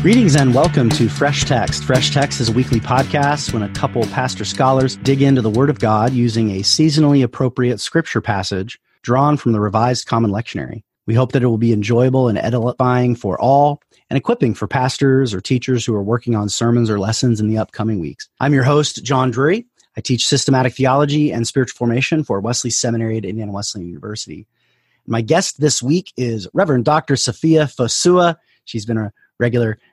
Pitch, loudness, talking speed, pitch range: 125 Hz, -16 LUFS, 195 wpm, 115-140 Hz